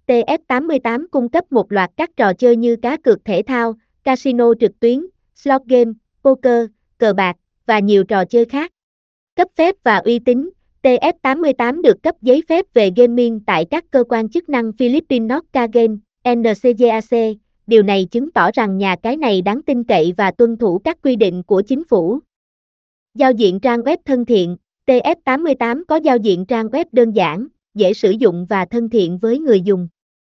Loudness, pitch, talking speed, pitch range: -15 LUFS, 240 Hz, 180 wpm, 215-270 Hz